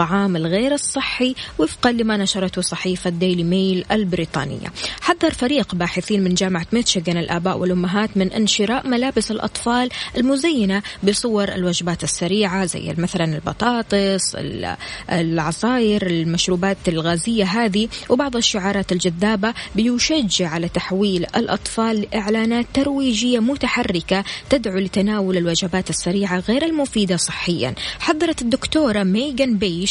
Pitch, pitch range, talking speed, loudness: 200 Hz, 180-235 Hz, 110 wpm, -19 LUFS